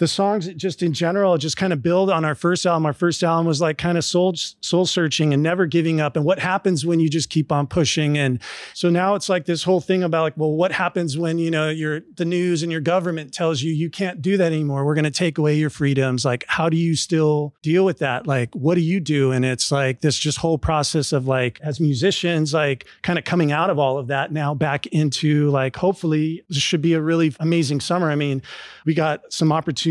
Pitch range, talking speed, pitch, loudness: 150-175 Hz, 245 wpm, 160 Hz, -20 LUFS